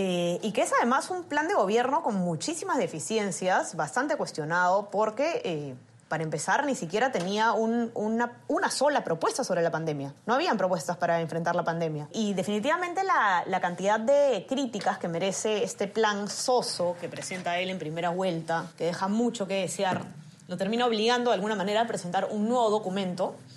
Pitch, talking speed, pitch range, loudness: 195 Hz, 180 wpm, 175-235 Hz, -28 LUFS